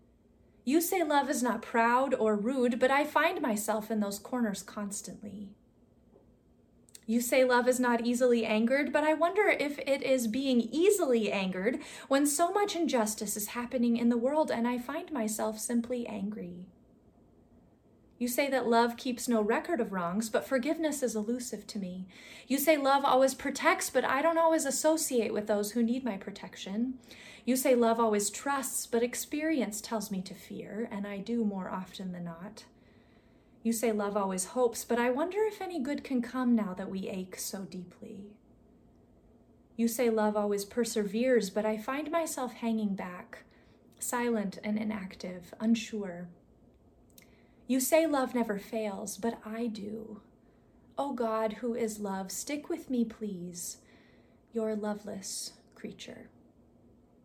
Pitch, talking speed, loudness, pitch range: 235 Hz, 155 wpm, -31 LUFS, 210-265 Hz